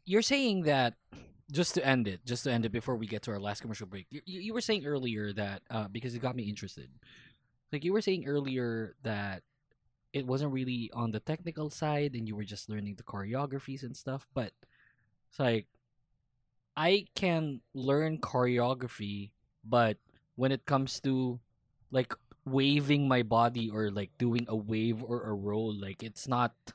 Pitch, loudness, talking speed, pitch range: 125 Hz, -33 LUFS, 180 wpm, 110-140 Hz